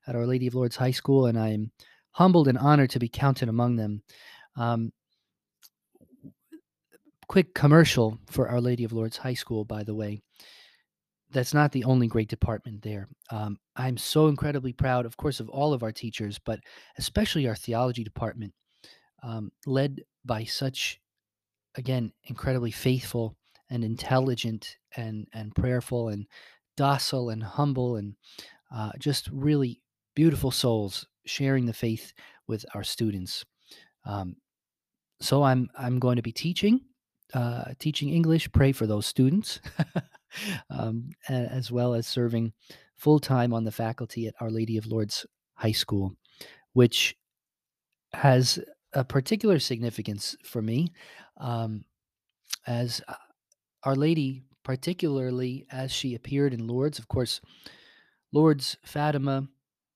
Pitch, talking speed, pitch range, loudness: 125 Hz, 135 wpm, 115-140 Hz, -27 LUFS